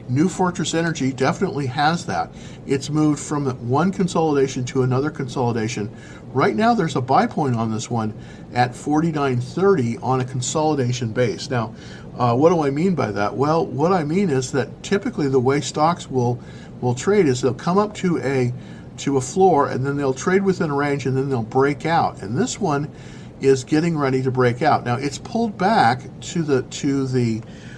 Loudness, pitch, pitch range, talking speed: -20 LUFS, 135 Hz, 125-165 Hz, 190 wpm